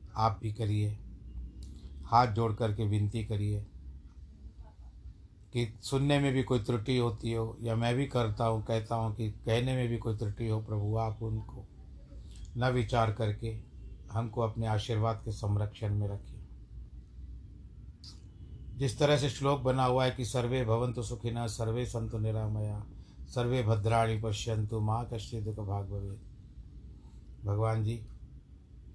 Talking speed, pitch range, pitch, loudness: 140 wpm, 100-115 Hz, 110 Hz, -32 LUFS